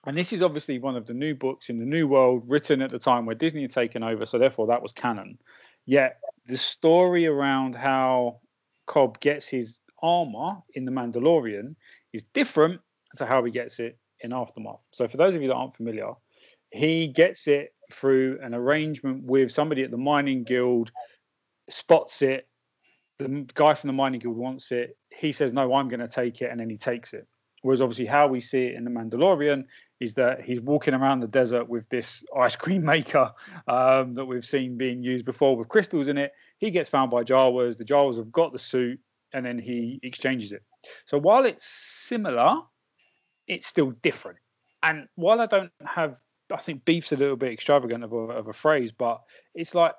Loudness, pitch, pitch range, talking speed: -25 LUFS, 130 Hz, 125-150 Hz, 200 wpm